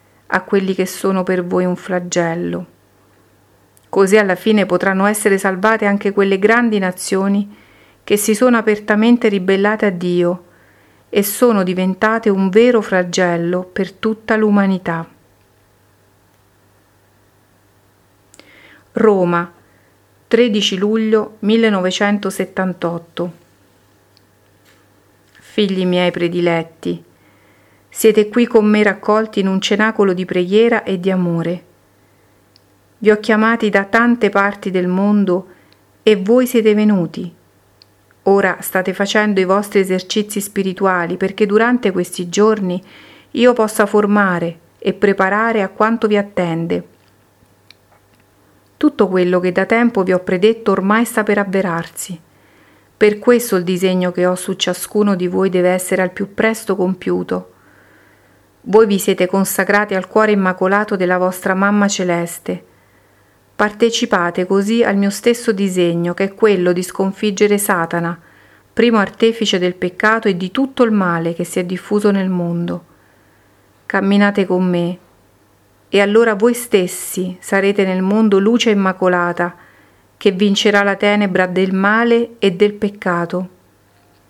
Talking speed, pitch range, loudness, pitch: 125 wpm, 165-210 Hz, -15 LUFS, 190 Hz